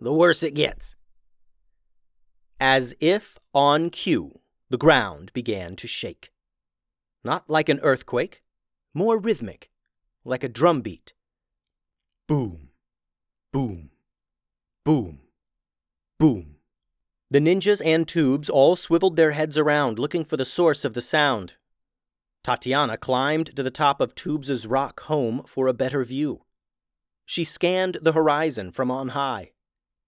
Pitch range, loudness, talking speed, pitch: 115-155 Hz, -23 LUFS, 125 wpm, 140 Hz